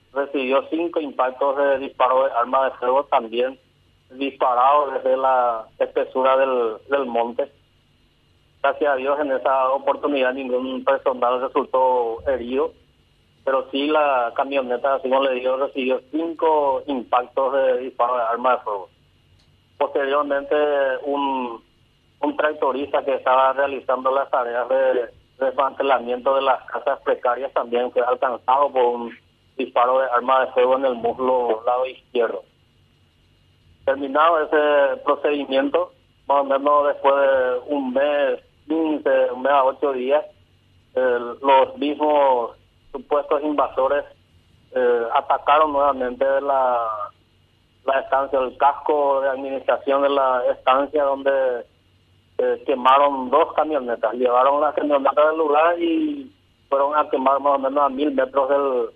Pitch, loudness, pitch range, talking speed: 135 Hz, -20 LUFS, 130-145 Hz, 130 wpm